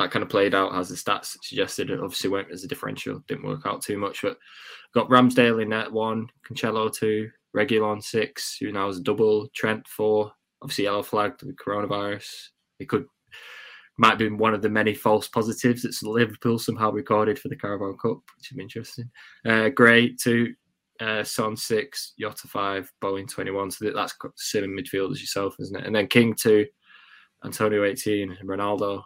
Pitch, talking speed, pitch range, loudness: 110 Hz, 190 wpm, 100-115 Hz, -24 LUFS